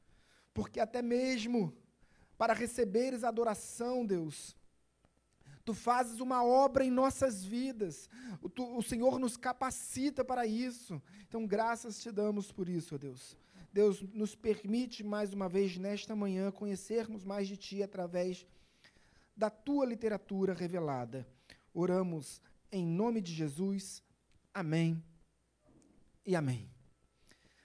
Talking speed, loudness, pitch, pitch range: 120 wpm, -36 LUFS, 205 Hz, 180-235 Hz